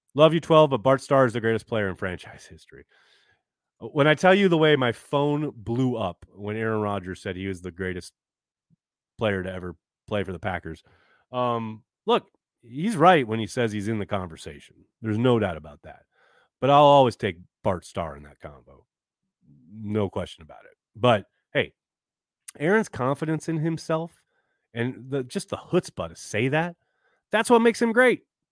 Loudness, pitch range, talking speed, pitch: -24 LUFS, 95-150 Hz, 180 wpm, 115 Hz